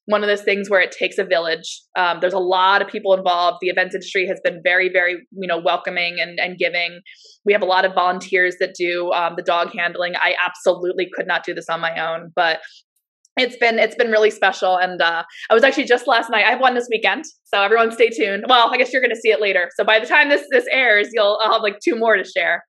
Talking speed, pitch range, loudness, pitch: 260 wpm, 175-220 Hz, -17 LUFS, 185 Hz